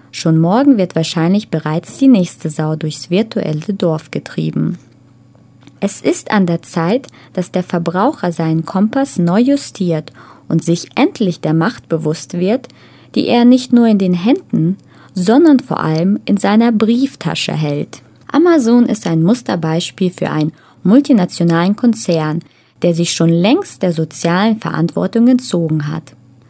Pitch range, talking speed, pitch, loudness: 160-225 Hz, 140 wpm, 175 Hz, -14 LUFS